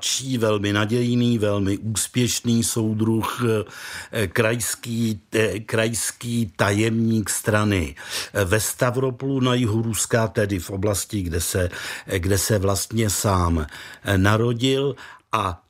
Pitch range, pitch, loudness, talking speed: 100-120 Hz, 110 Hz, -22 LUFS, 100 wpm